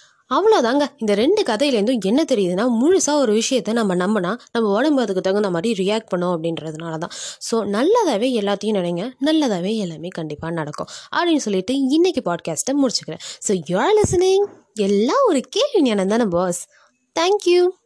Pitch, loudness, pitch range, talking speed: 230 Hz, -19 LUFS, 190-295 Hz, 145 wpm